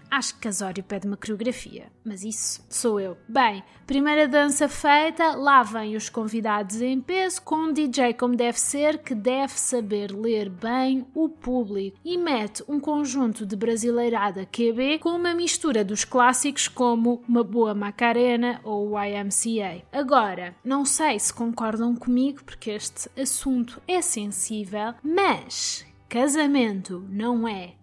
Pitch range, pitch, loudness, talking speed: 215-280 Hz, 240 Hz, -24 LUFS, 140 wpm